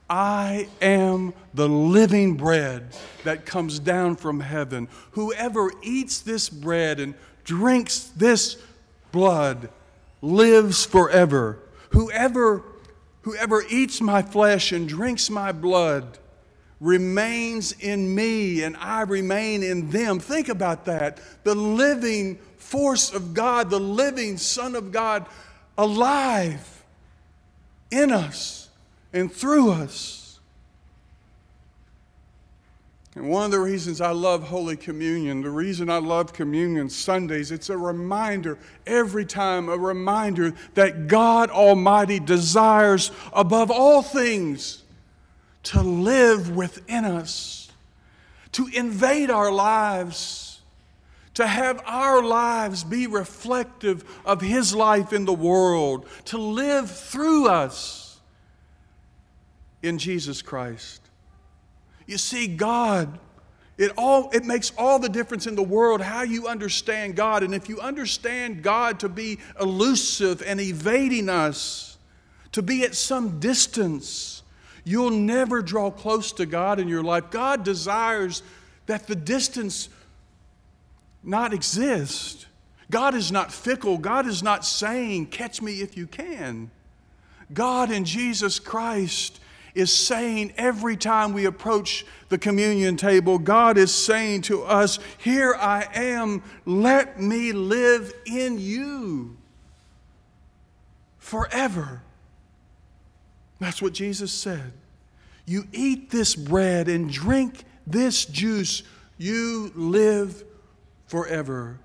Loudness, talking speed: -22 LUFS, 115 wpm